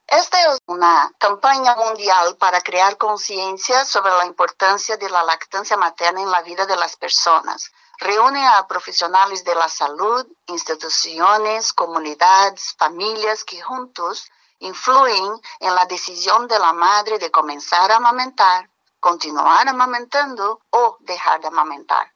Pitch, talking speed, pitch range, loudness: 200 Hz, 135 wpm, 180-240 Hz, -17 LUFS